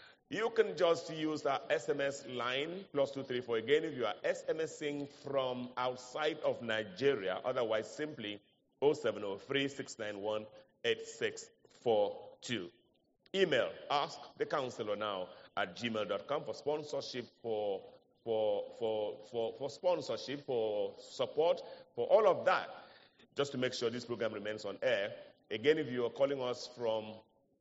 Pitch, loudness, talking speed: 150 Hz, -36 LUFS, 135 wpm